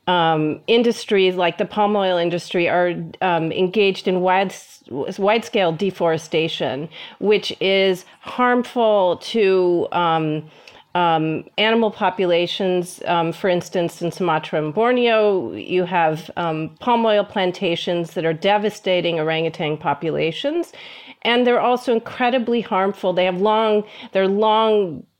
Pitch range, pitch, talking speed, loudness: 170-215 Hz, 185 Hz, 120 wpm, -19 LUFS